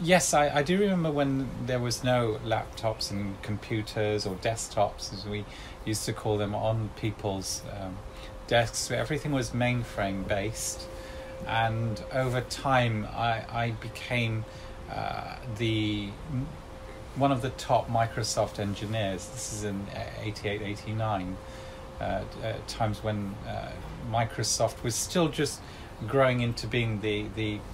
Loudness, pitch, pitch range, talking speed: -30 LUFS, 110 Hz, 105-120 Hz, 130 wpm